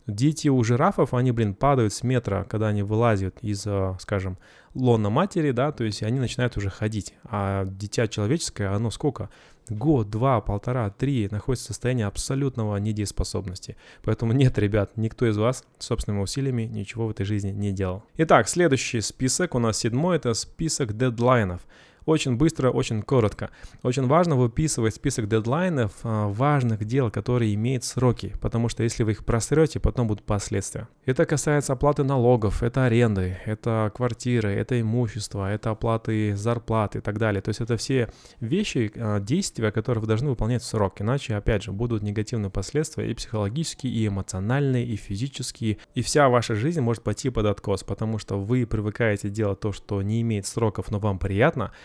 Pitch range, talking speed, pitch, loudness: 105-125 Hz, 165 wpm, 115 Hz, -25 LUFS